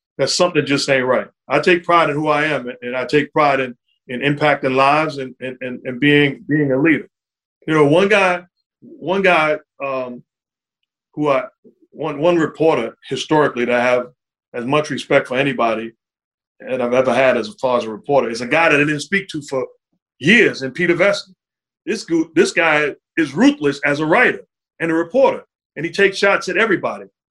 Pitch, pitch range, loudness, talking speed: 145 Hz, 130-175 Hz, -17 LUFS, 200 wpm